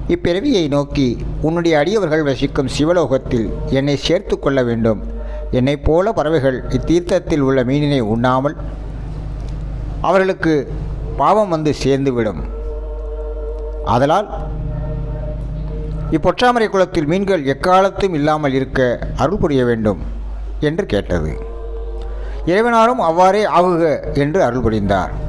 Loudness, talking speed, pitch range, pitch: -17 LUFS, 95 wpm, 130-160 Hz, 150 Hz